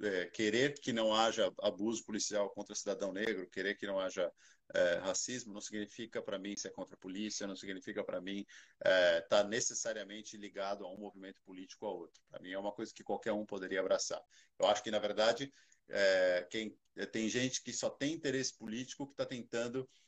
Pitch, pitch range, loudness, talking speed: 105 Hz, 100-115 Hz, -37 LUFS, 200 wpm